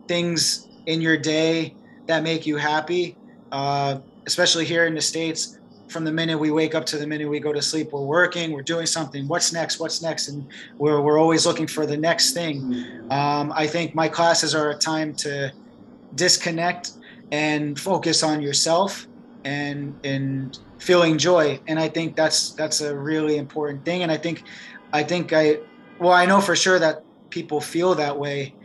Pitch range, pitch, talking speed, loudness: 150-170 Hz, 155 Hz, 185 wpm, -21 LUFS